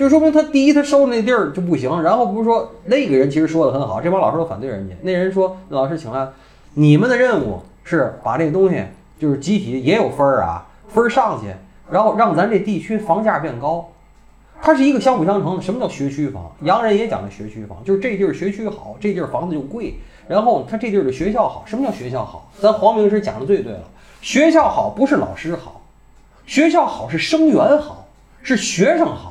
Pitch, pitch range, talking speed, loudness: 200 Hz, 150-245 Hz, 330 characters per minute, -17 LUFS